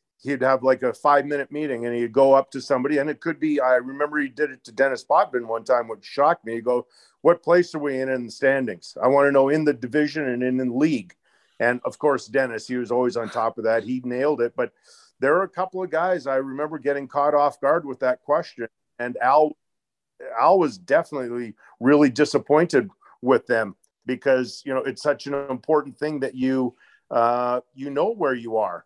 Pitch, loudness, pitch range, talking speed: 135 Hz, -22 LUFS, 125-145 Hz, 220 wpm